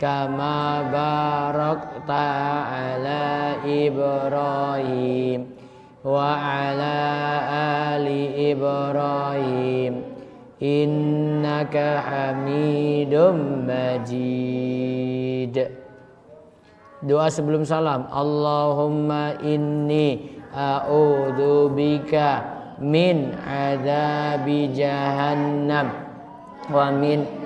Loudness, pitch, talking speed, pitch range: -22 LUFS, 145 Hz, 50 wpm, 140-150 Hz